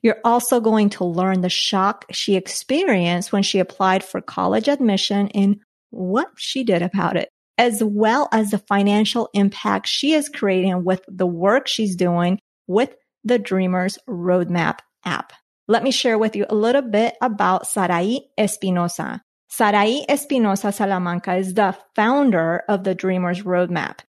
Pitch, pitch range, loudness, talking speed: 200 Hz, 185-225 Hz, -20 LUFS, 150 wpm